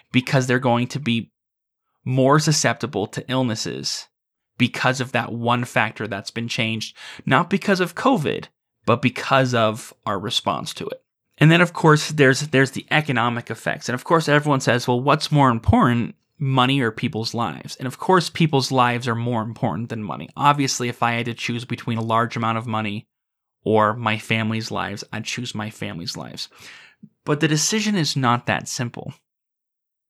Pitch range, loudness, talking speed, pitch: 115-140 Hz, -21 LUFS, 175 wpm, 125 Hz